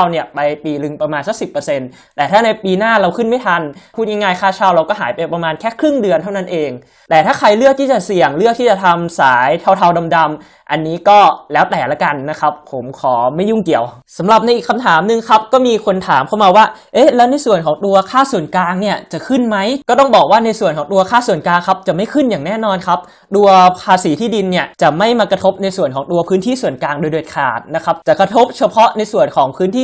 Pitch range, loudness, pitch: 160-225 Hz, -13 LUFS, 190 Hz